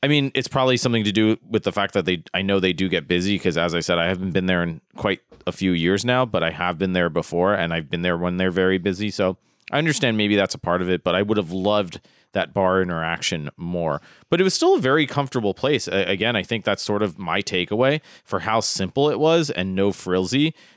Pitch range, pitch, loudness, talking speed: 90-115 Hz, 95 Hz, -21 LUFS, 255 wpm